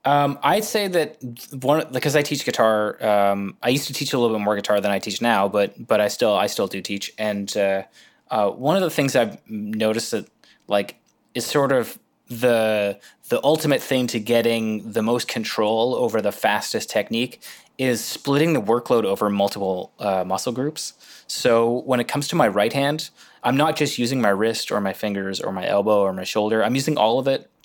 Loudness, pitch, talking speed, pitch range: -21 LUFS, 115 Hz, 205 wpm, 100-135 Hz